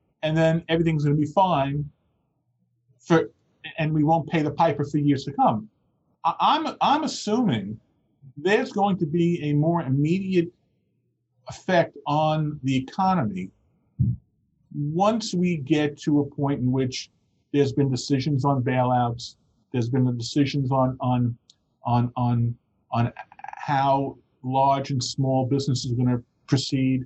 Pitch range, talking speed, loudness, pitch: 125-160 Hz, 140 wpm, -24 LUFS, 140 Hz